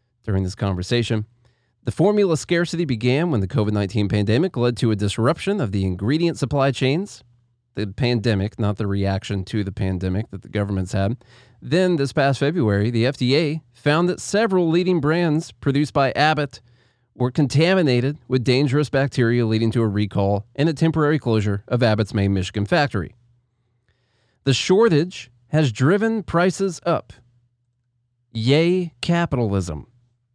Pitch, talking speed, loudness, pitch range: 120 Hz, 140 wpm, -21 LUFS, 110-150 Hz